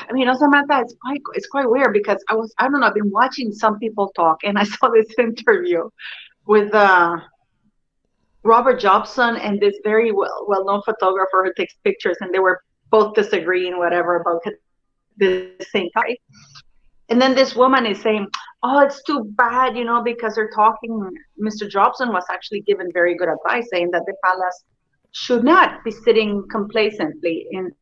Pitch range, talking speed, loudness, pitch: 190-245 Hz, 175 wpm, -18 LUFS, 215 Hz